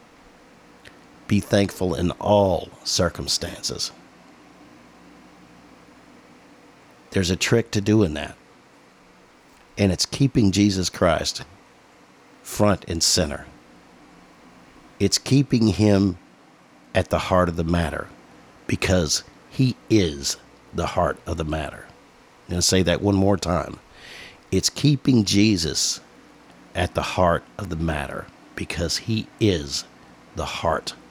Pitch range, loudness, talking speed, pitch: 85-105 Hz, -22 LUFS, 120 wpm, 95 Hz